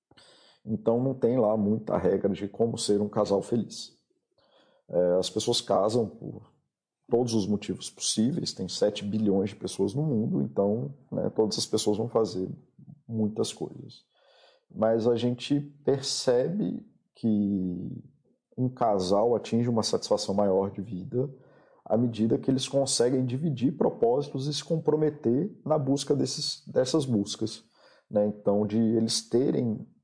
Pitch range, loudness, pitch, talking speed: 105-135 Hz, -28 LUFS, 115 Hz, 140 wpm